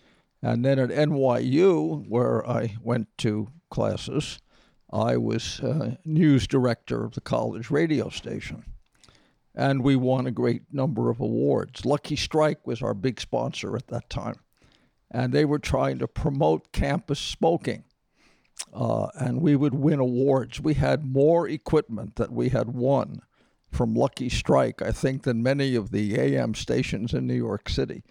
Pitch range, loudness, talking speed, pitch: 115-145 Hz, -25 LUFS, 155 wpm, 130 Hz